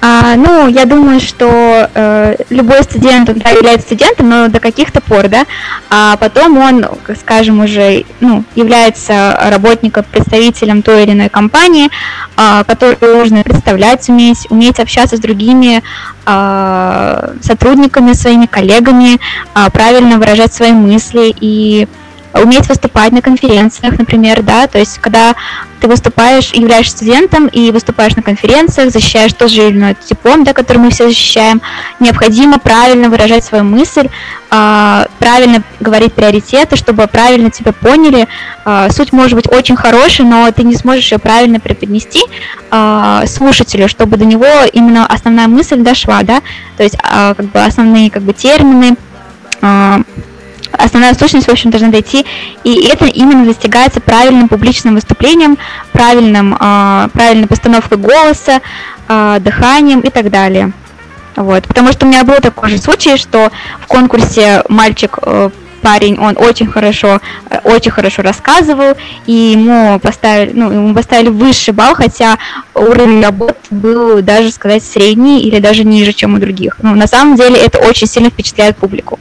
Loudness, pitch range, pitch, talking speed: -6 LUFS, 215-245 Hz, 230 Hz, 150 wpm